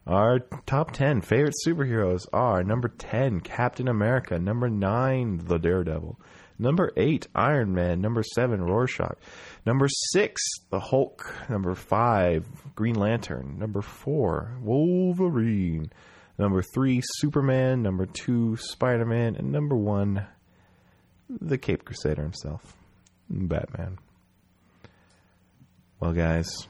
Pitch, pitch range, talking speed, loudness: 110 Hz, 90-125 Hz, 110 wpm, -26 LUFS